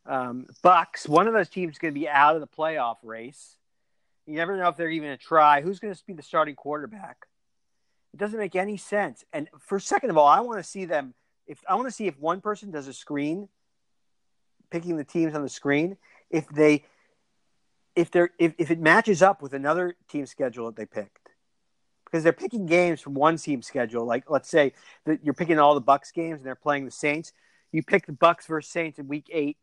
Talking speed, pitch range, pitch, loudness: 225 wpm, 145-180 Hz, 160 Hz, -24 LUFS